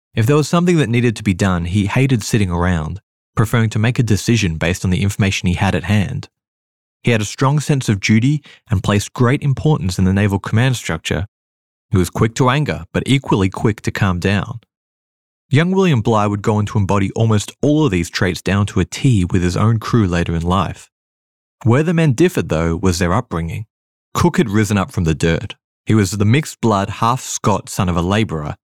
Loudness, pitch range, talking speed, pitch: -17 LUFS, 90-120 Hz, 215 wpm, 105 Hz